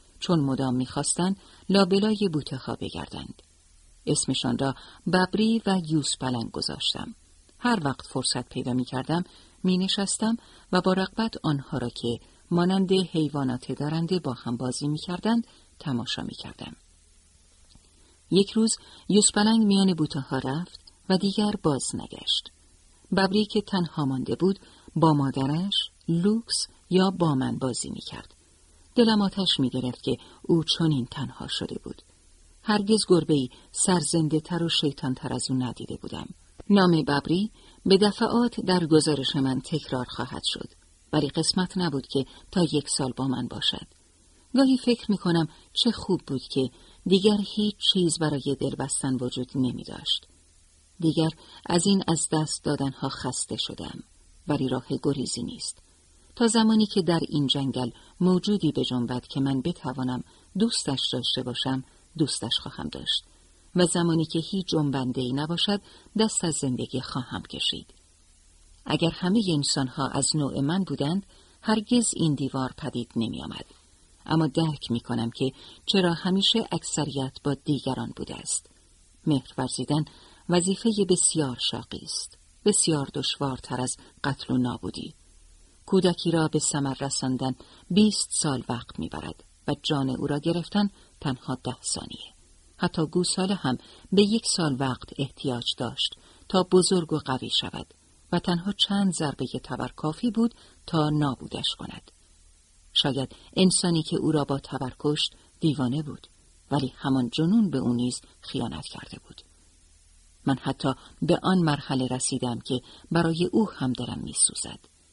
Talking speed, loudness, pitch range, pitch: 140 wpm, -26 LUFS, 125-180 Hz, 145 Hz